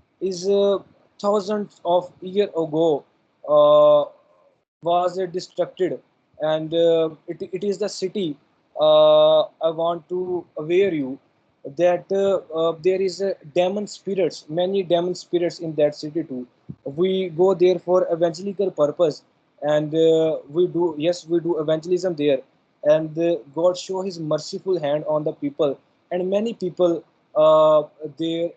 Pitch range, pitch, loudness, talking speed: 160-195 Hz, 175 Hz, -21 LUFS, 145 wpm